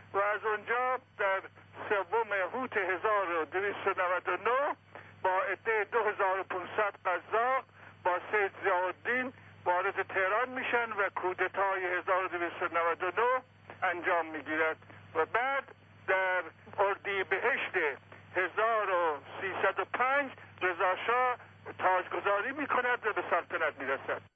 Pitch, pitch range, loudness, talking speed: 195 Hz, 180-220 Hz, -31 LUFS, 85 wpm